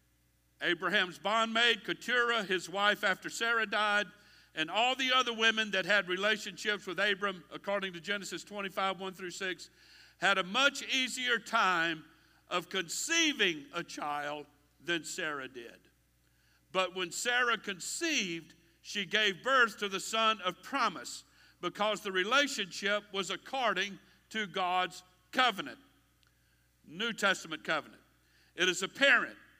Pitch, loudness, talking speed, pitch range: 195 Hz, -31 LUFS, 130 wpm, 170-220 Hz